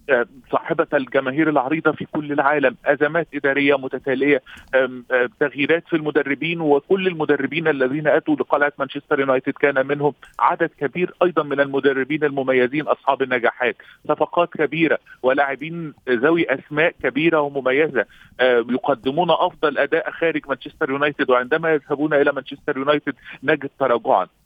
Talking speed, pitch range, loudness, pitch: 125 wpm, 135-155 Hz, -20 LUFS, 145 Hz